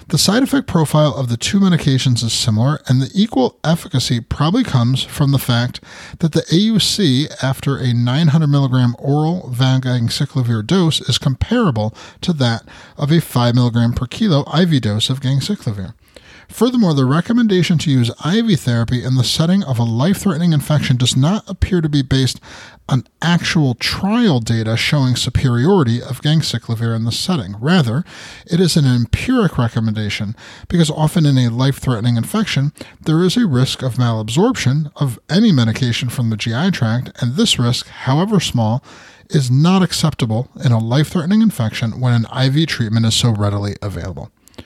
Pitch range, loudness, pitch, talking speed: 120-165 Hz, -16 LUFS, 135 Hz, 160 wpm